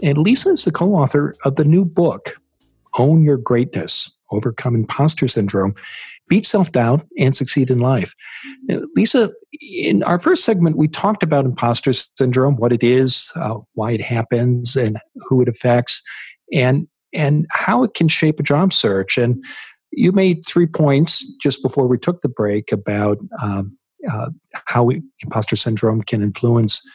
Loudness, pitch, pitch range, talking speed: -16 LUFS, 135 Hz, 120-170 Hz, 160 wpm